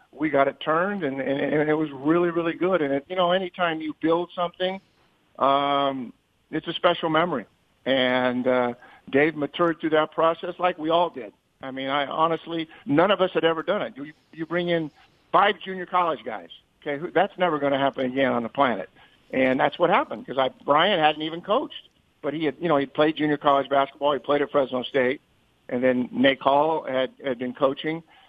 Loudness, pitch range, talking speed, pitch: -24 LUFS, 135-170 Hz, 210 wpm, 150 Hz